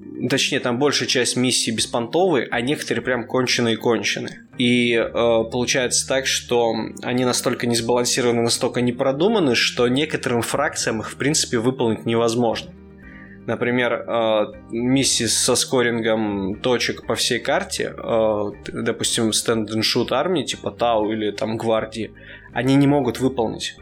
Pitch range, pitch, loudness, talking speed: 110-125 Hz, 120 Hz, -20 LUFS, 140 wpm